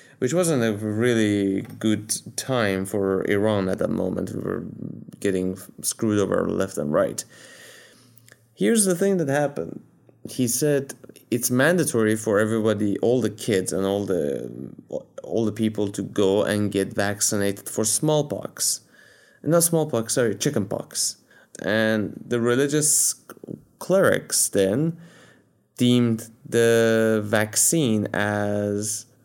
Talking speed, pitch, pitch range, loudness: 120 wpm, 110 Hz, 105-125 Hz, -22 LUFS